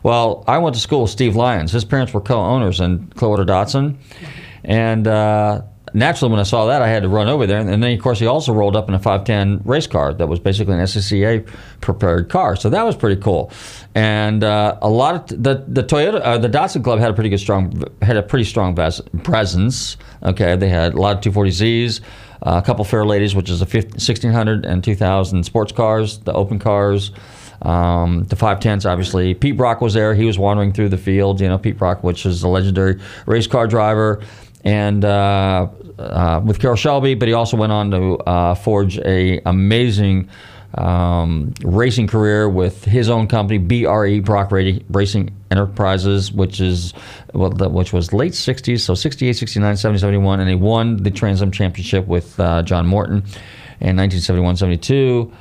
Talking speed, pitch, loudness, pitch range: 200 wpm, 105 Hz, -16 LUFS, 95-115 Hz